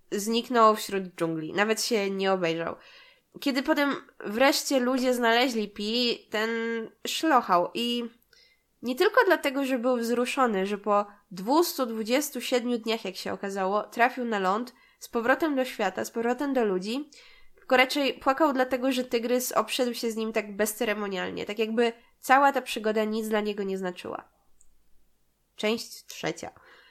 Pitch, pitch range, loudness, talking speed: 235 Hz, 210-260 Hz, -27 LUFS, 145 wpm